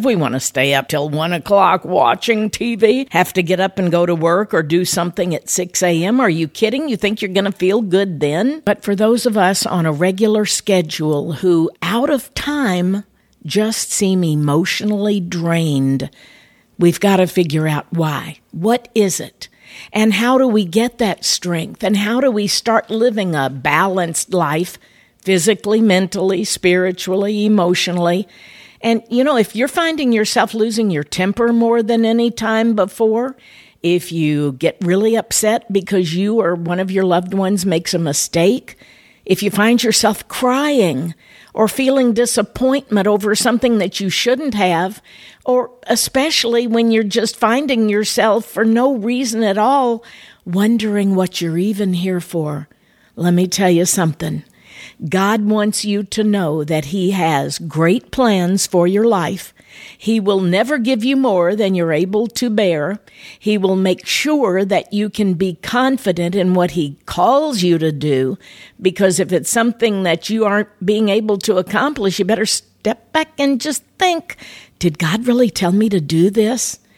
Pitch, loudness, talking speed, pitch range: 200 Hz, -16 LUFS, 170 wpm, 175-225 Hz